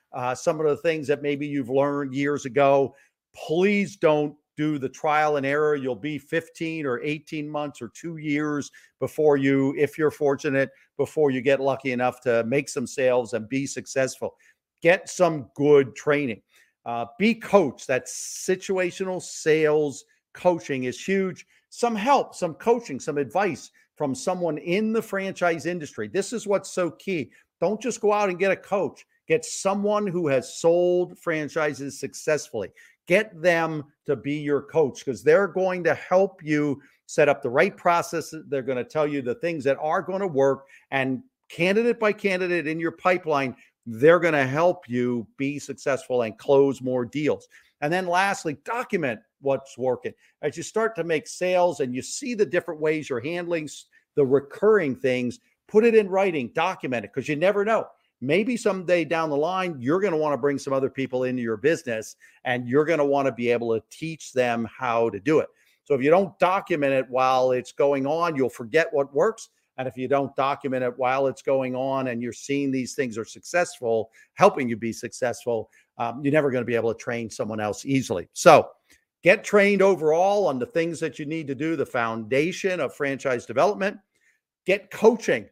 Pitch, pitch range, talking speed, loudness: 150 Hz, 135-180 Hz, 185 wpm, -24 LUFS